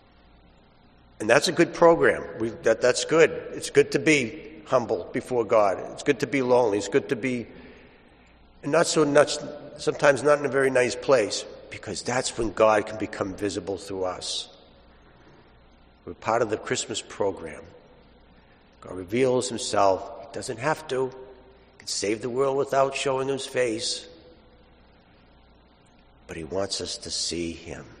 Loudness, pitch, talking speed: -24 LUFS, 120 Hz, 155 wpm